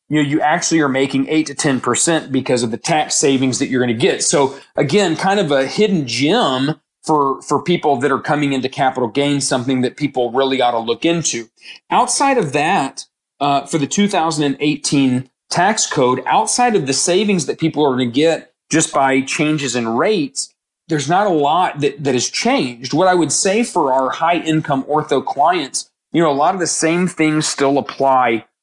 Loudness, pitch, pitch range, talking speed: -16 LUFS, 145 Hz, 130-160 Hz, 200 wpm